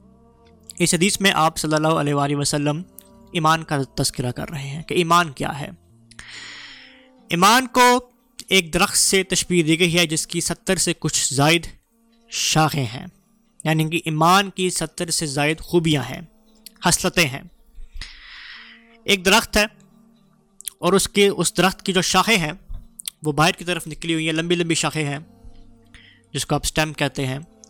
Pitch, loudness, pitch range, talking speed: 175 Hz, -19 LUFS, 150-195 Hz, 165 wpm